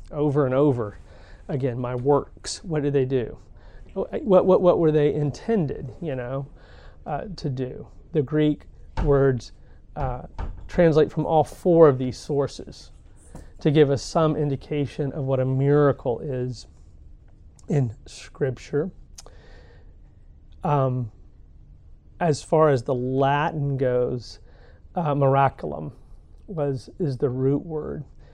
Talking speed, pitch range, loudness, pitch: 125 wpm, 105-150 Hz, -23 LUFS, 135 Hz